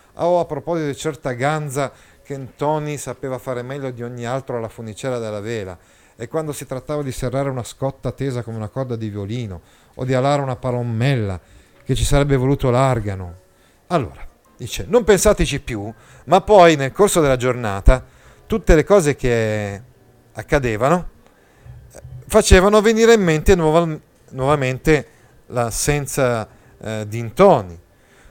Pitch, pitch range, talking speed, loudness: 130 Hz, 115-150 Hz, 145 wpm, -19 LUFS